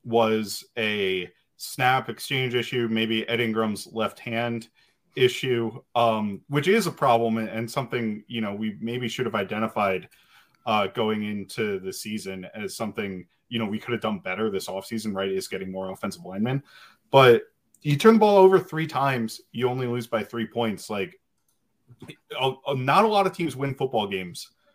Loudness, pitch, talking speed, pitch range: -25 LUFS, 115 Hz, 170 wpm, 110-130 Hz